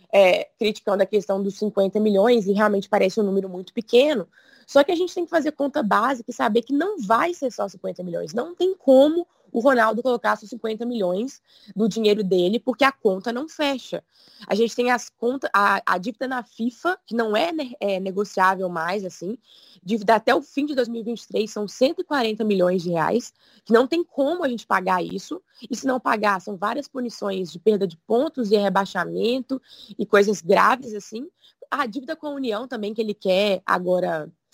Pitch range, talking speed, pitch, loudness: 200-265 Hz, 195 wpm, 230 Hz, -22 LUFS